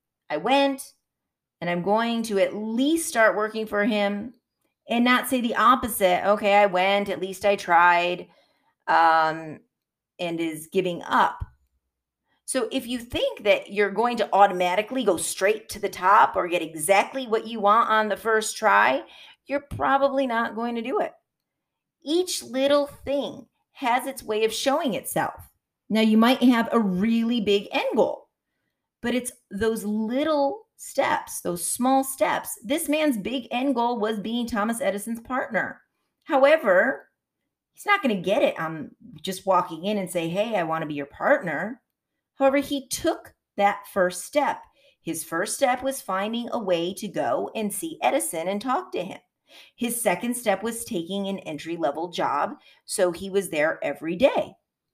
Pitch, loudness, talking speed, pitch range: 220 Hz, -24 LUFS, 165 wpm, 190-265 Hz